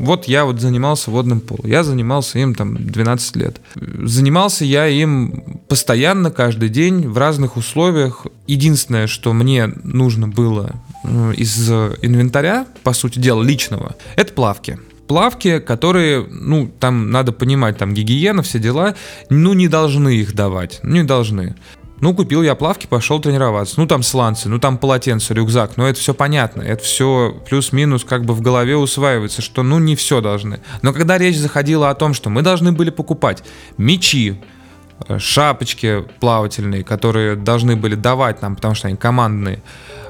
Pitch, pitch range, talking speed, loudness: 125 Hz, 115-145 Hz, 155 wpm, -15 LUFS